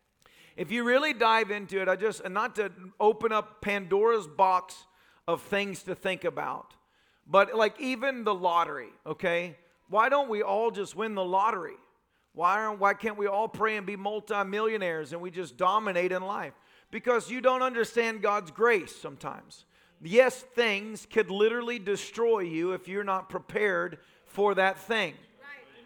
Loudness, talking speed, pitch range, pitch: -28 LUFS, 160 wpm, 185-225 Hz, 205 Hz